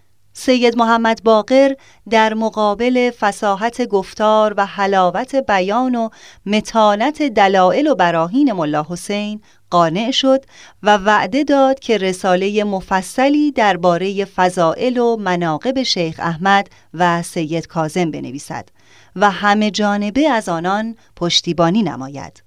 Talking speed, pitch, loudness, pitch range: 110 wpm, 205 Hz, -16 LUFS, 175-230 Hz